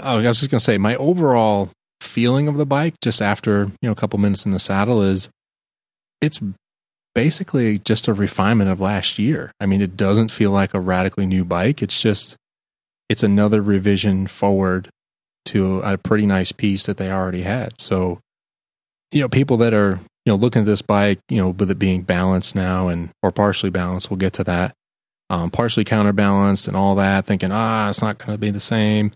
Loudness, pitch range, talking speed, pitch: -18 LUFS, 95-110 Hz, 200 wpm, 100 Hz